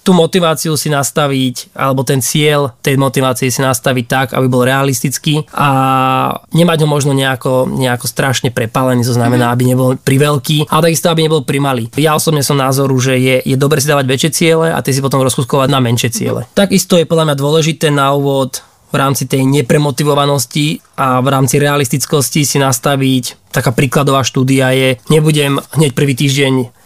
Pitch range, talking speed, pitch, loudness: 130-150 Hz, 175 wpm, 140 Hz, -12 LUFS